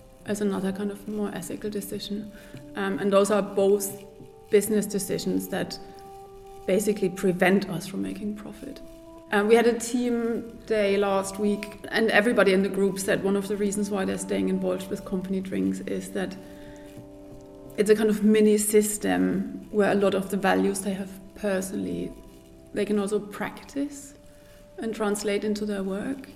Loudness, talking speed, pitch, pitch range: -26 LUFS, 165 wpm, 200 Hz, 190-210 Hz